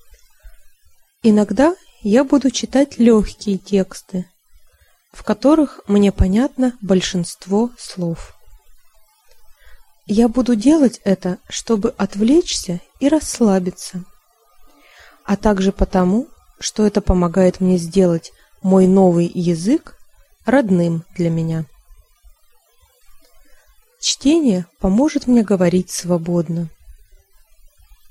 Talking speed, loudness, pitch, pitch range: 85 wpm, -17 LUFS, 205 Hz, 180-245 Hz